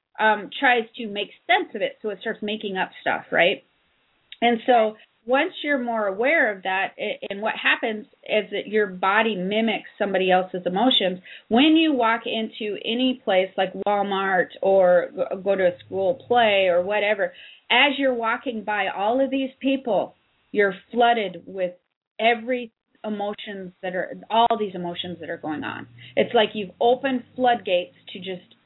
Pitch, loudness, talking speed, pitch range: 215 Hz, -22 LUFS, 165 wpm, 190-240 Hz